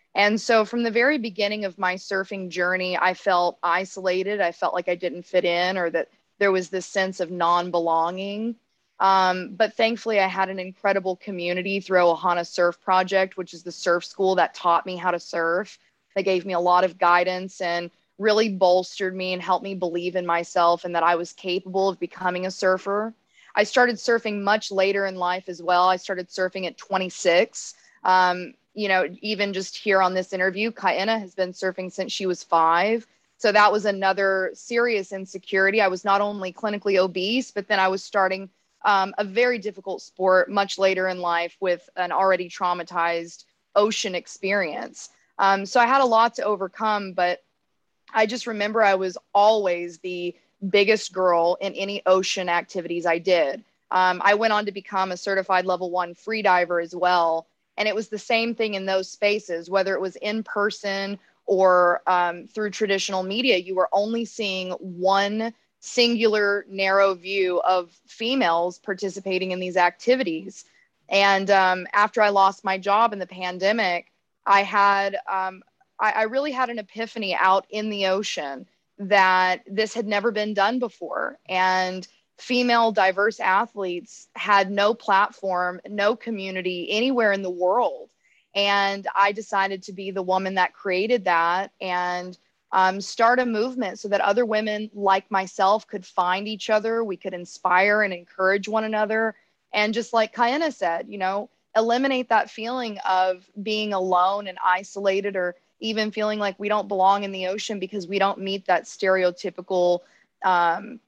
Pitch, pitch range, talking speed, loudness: 195 Hz, 180-210 Hz, 170 wpm, -23 LUFS